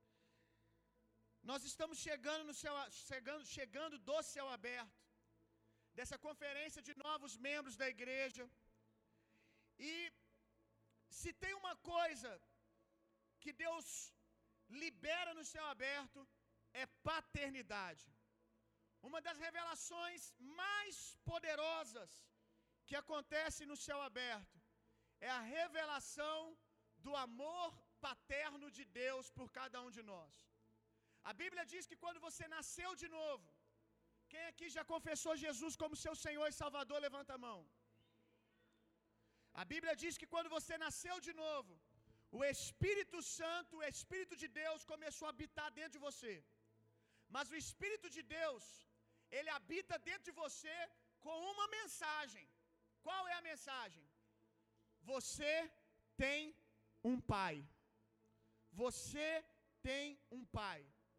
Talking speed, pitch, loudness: 120 wpm, 285 Hz, -47 LUFS